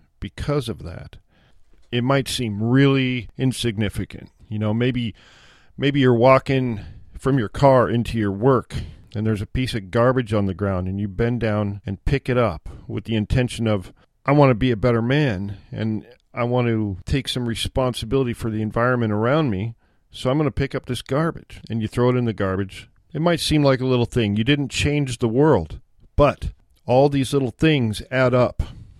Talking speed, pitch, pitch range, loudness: 195 wpm, 120 Hz, 105-130 Hz, -21 LUFS